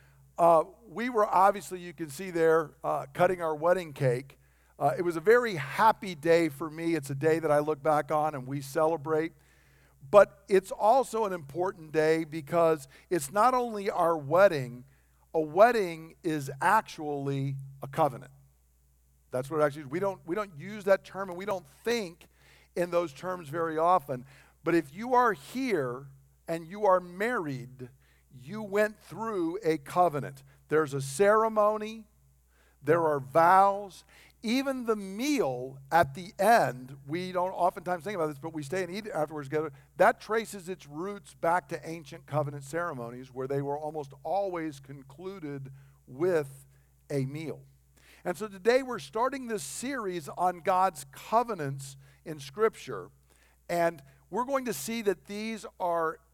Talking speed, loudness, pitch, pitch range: 160 wpm, -29 LUFS, 165 Hz, 140-195 Hz